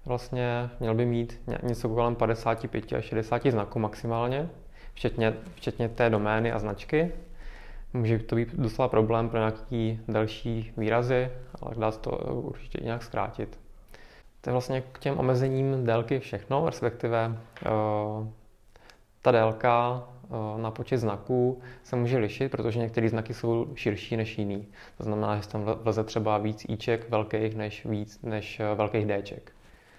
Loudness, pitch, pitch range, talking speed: -29 LUFS, 115 Hz, 110-125 Hz, 145 wpm